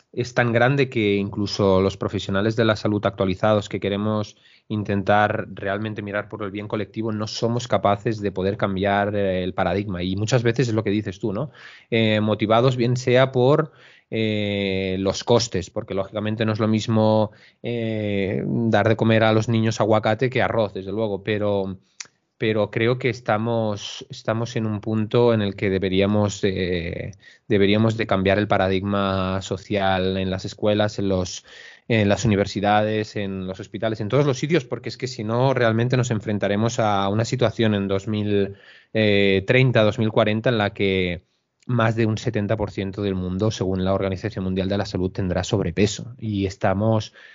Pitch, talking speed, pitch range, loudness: 105 Hz, 165 wpm, 100-115 Hz, -22 LUFS